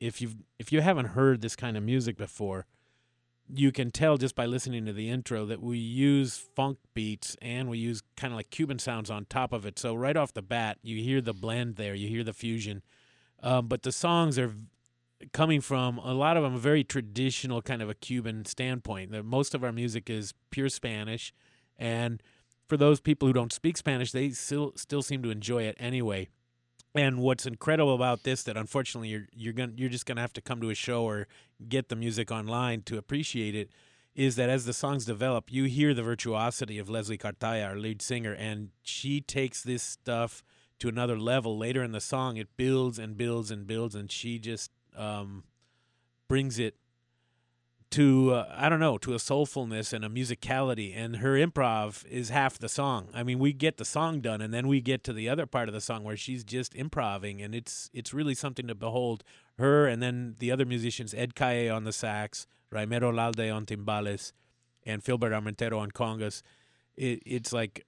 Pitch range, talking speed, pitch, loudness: 110-130 Hz, 205 wpm, 120 Hz, -31 LUFS